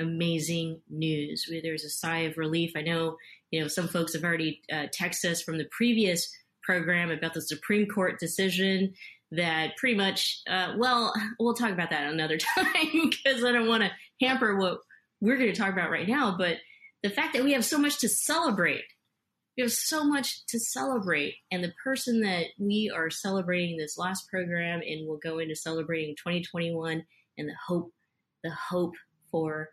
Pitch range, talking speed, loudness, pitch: 160-225 Hz, 185 wpm, -28 LUFS, 175 Hz